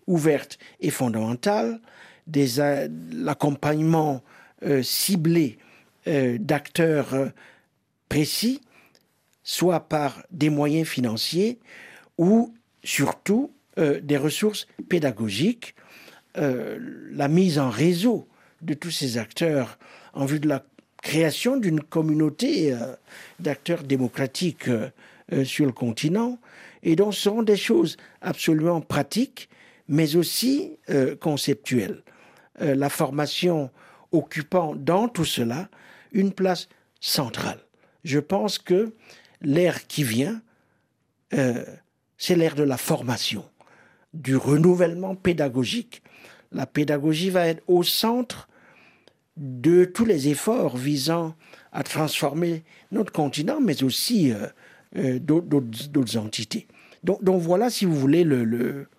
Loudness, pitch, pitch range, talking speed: -24 LUFS, 155 Hz, 140-185 Hz, 115 wpm